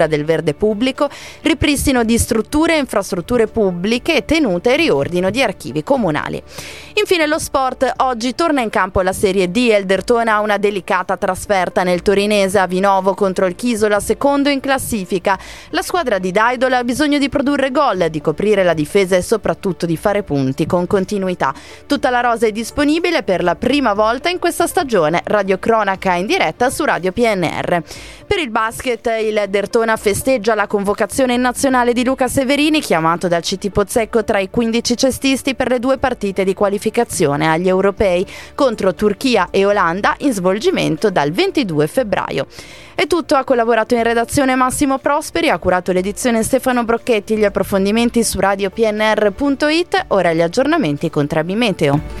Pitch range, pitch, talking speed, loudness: 195-260 Hz, 220 Hz, 160 wpm, -16 LUFS